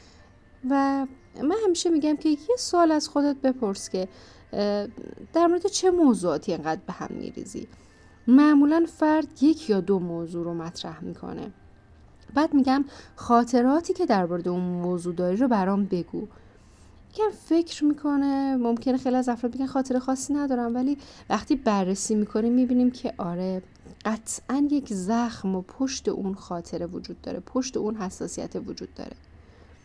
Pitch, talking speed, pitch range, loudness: 250 Hz, 145 wpm, 190-290 Hz, -25 LUFS